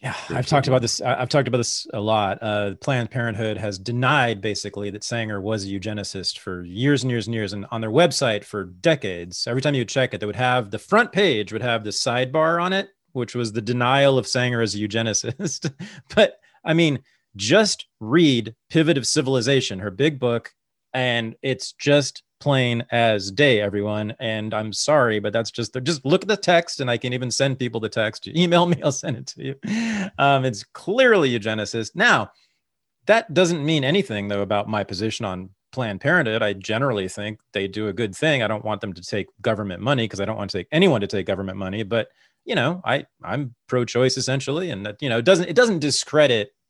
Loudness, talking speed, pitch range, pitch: -22 LUFS, 210 wpm, 105-145 Hz, 120 Hz